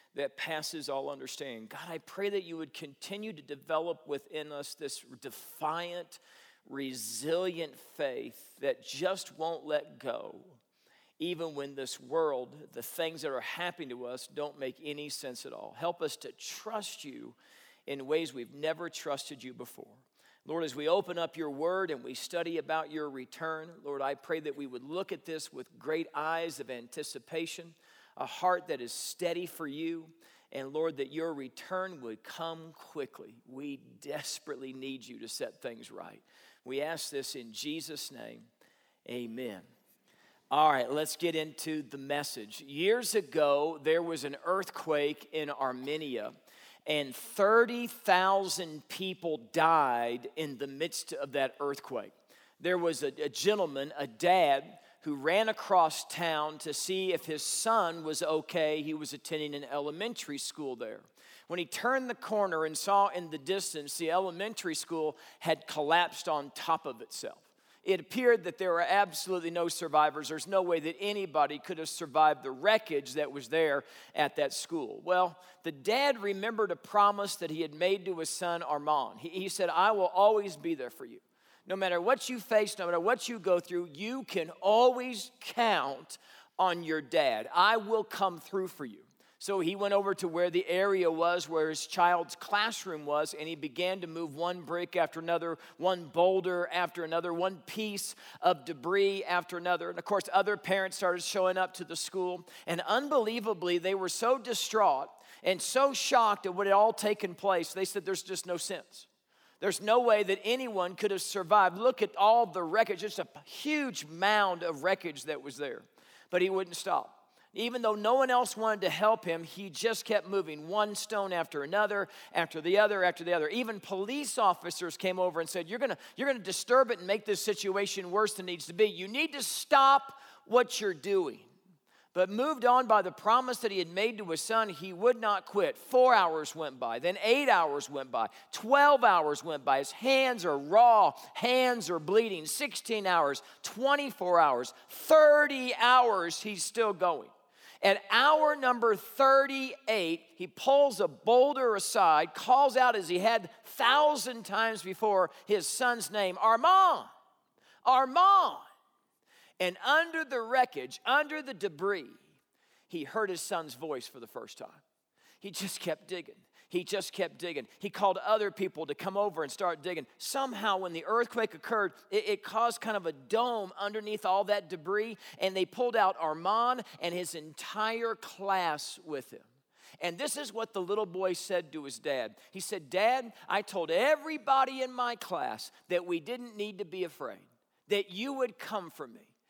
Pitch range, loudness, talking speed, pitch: 160-220 Hz, -31 LUFS, 175 wpm, 185 Hz